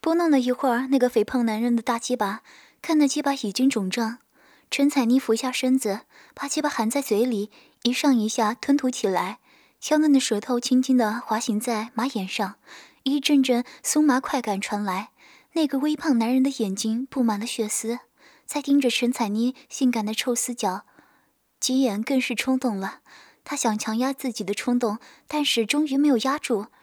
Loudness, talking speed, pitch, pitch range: -24 LUFS, 265 characters per minute, 245 Hz, 220-275 Hz